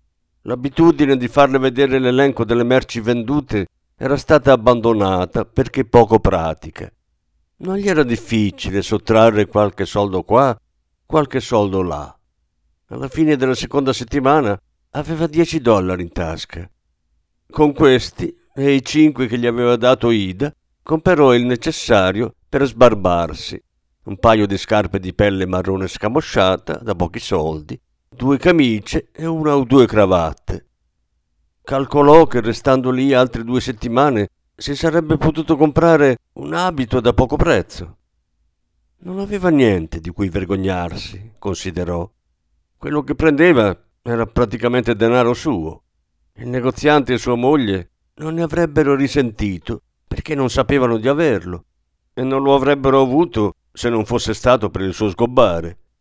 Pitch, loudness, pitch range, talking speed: 115 Hz, -16 LUFS, 90-135 Hz, 135 wpm